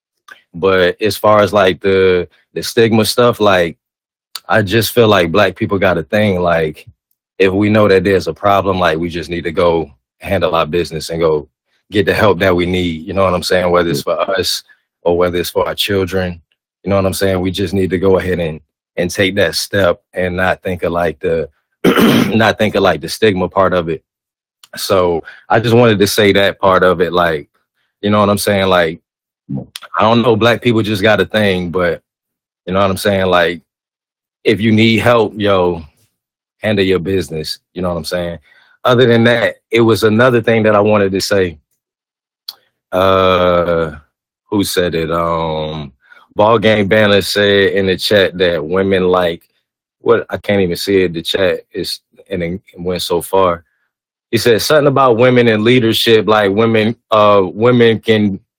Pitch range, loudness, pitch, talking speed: 90-110 Hz, -13 LUFS, 95 Hz, 195 wpm